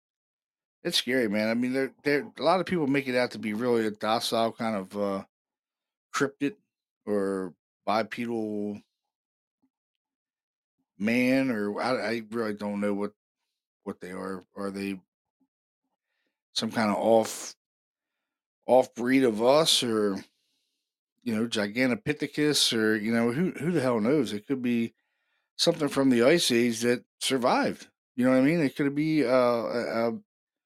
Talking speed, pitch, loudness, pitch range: 155 wpm, 120 Hz, -27 LUFS, 105-140 Hz